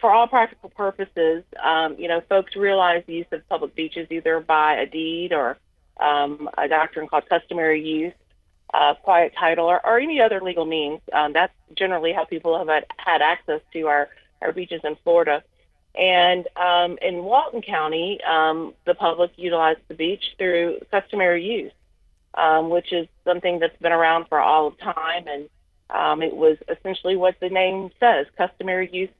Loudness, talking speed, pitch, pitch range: -21 LUFS, 175 wpm, 170 Hz, 160-185 Hz